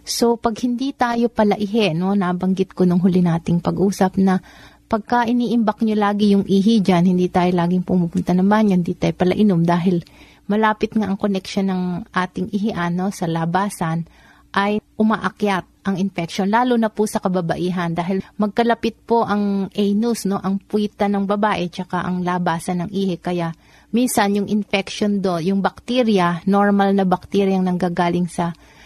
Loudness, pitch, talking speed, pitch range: -19 LUFS, 195 Hz, 160 wpm, 180-210 Hz